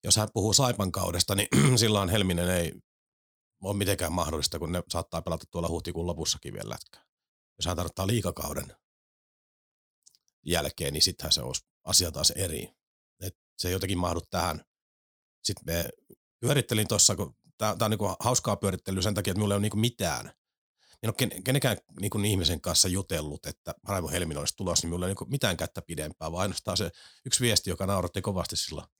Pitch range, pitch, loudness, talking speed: 85-105 Hz, 95 Hz, -28 LUFS, 180 wpm